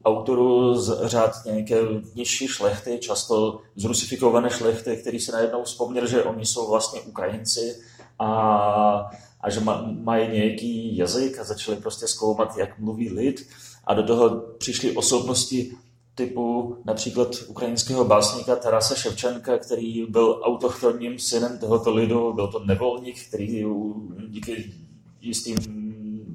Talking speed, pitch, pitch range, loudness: 125 wpm, 115 Hz, 110-120 Hz, -24 LUFS